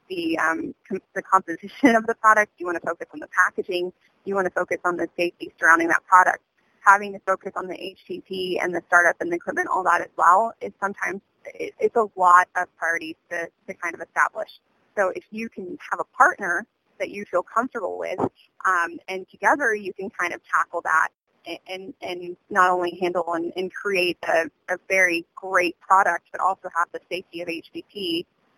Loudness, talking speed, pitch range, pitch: -22 LUFS, 200 wpm, 175-205 Hz, 185 Hz